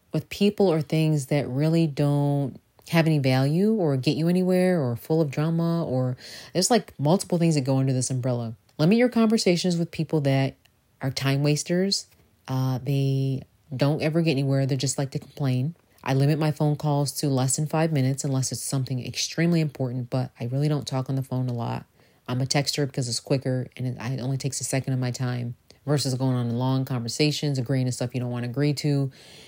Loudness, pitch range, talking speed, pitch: -25 LUFS, 130-155 Hz, 210 wpm, 140 Hz